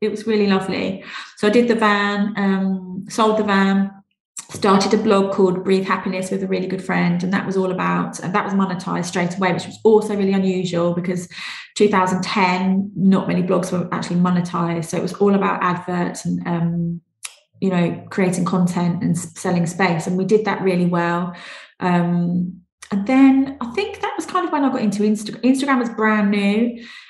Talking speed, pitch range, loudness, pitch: 195 wpm, 180-210 Hz, -19 LUFS, 190 Hz